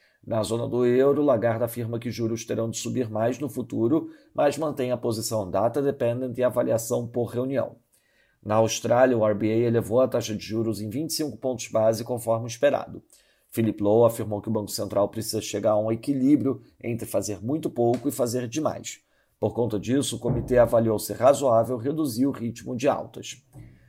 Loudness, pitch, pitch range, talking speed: -25 LUFS, 120 Hz, 110-130 Hz, 180 wpm